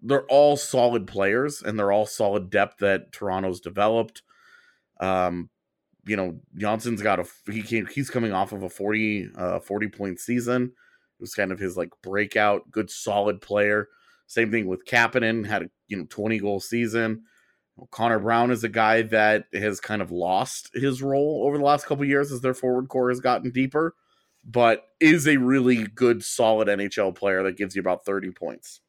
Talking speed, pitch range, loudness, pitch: 190 wpm, 100-125 Hz, -24 LUFS, 110 Hz